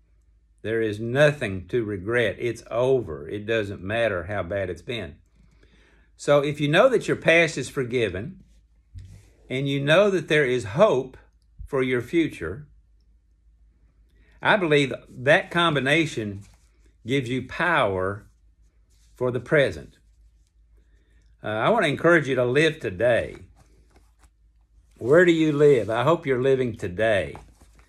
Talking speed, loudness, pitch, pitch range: 130 wpm, -22 LUFS, 110 Hz, 80-135 Hz